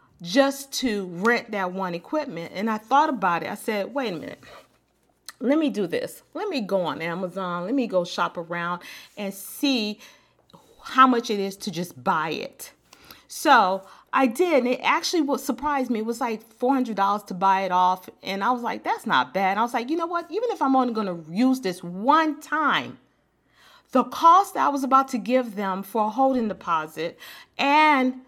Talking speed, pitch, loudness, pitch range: 195 wpm, 230 Hz, -23 LUFS, 190-275 Hz